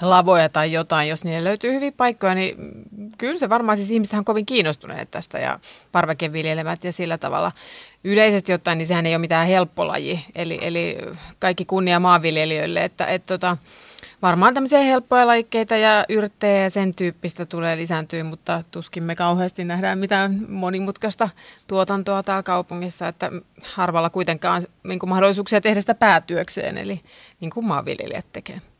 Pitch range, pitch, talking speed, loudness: 170-210 Hz, 185 Hz, 155 wpm, -20 LUFS